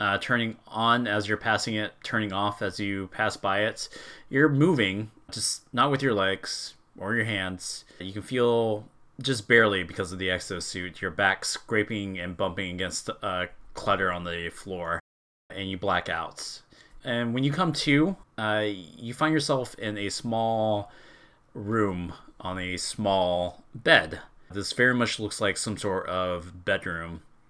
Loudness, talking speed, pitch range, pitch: -27 LUFS, 160 wpm, 95-115 Hz, 105 Hz